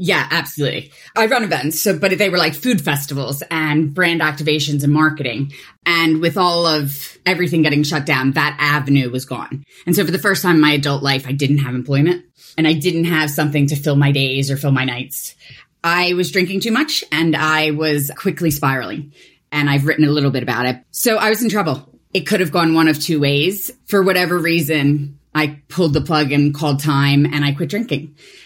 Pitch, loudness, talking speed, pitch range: 155 Hz, -16 LUFS, 215 wpm, 145-175 Hz